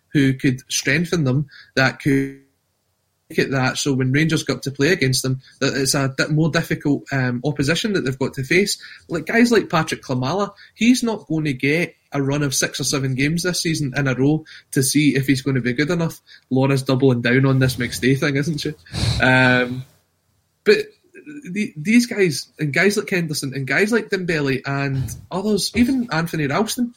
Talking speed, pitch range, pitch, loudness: 195 wpm, 135-175 Hz, 145 Hz, -19 LUFS